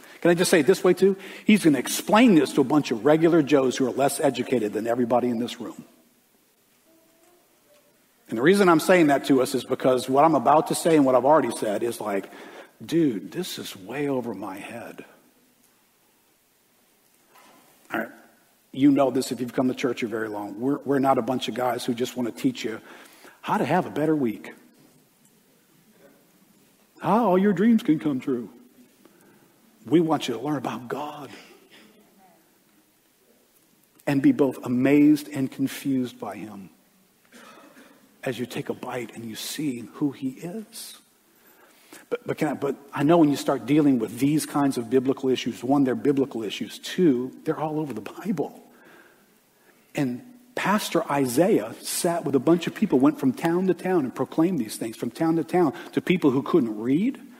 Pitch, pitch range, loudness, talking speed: 145 Hz, 130-175 Hz, -23 LUFS, 185 wpm